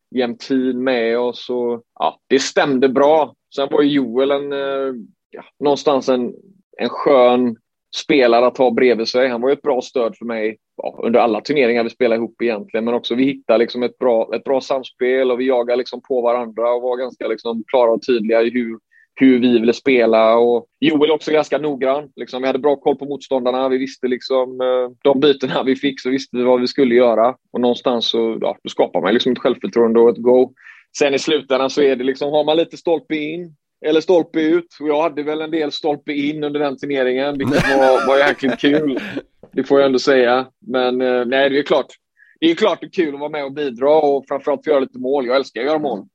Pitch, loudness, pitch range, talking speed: 130 Hz, -17 LUFS, 125-145 Hz, 220 wpm